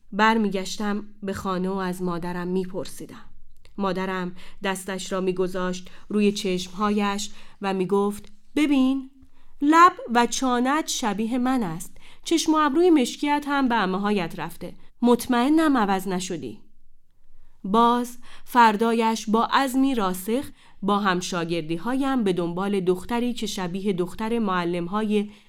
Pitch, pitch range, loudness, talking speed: 205 Hz, 185-245 Hz, -23 LUFS, 120 wpm